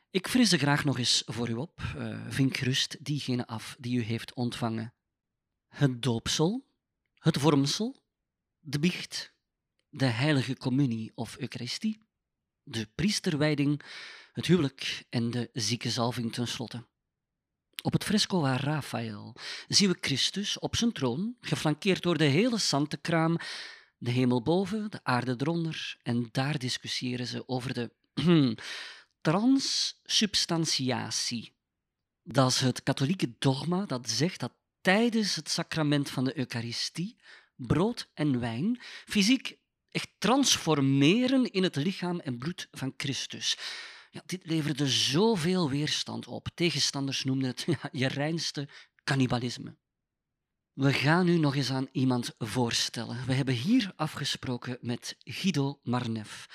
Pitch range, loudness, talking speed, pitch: 125-170 Hz, -29 LUFS, 125 wpm, 140 Hz